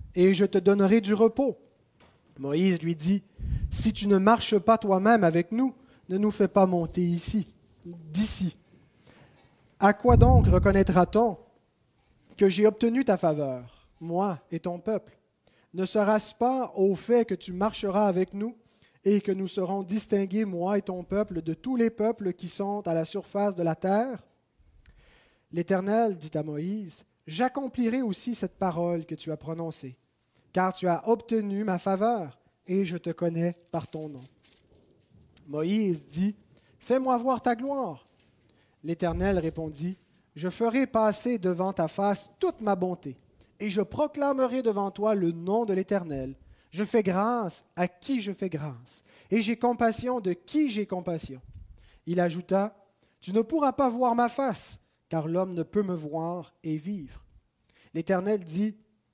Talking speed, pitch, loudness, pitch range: 155 wpm, 195 Hz, -27 LUFS, 170-215 Hz